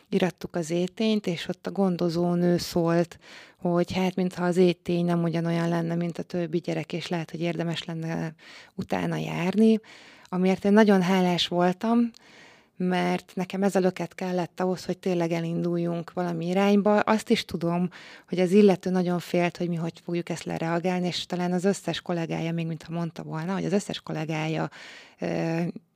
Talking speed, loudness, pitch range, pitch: 160 wpm, -26 LUFS, 170-185 Hz, 175 Hz